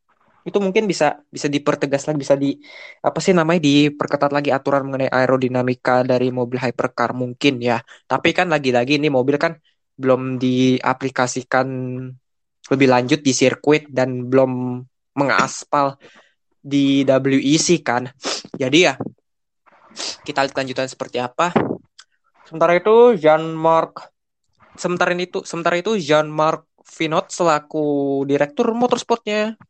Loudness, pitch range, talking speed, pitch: -18 LUFS, 130-165 Hz, 125 wpm, 140 Hz